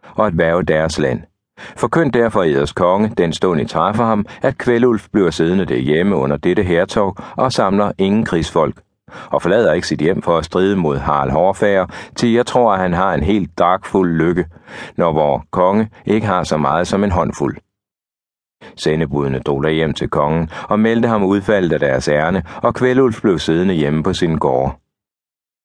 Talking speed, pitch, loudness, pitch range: 180 wpm, 95 Hz, -16 LUFS, 80-110 Hz